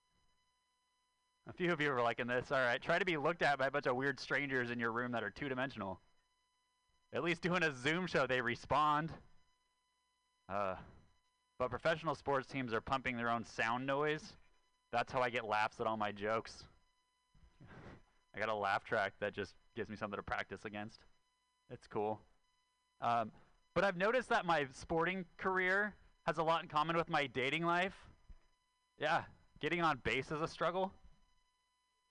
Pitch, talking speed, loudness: 155 Hz, 175 wpm, -38 LUFS